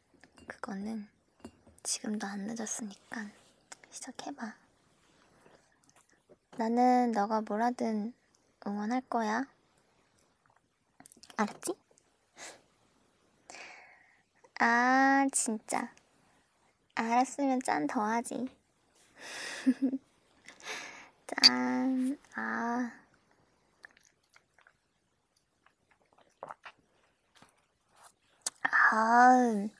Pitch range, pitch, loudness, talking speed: 220-260 Hz, 235 Hz, -30 LUFS, 90 characters per minute